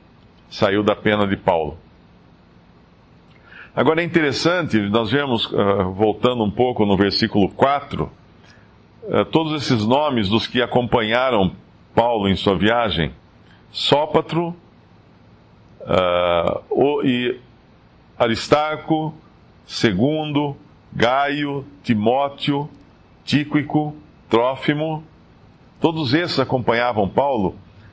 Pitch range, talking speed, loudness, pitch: 100-145 Hz, 80 wpm, -19 LUFS, 120 Hz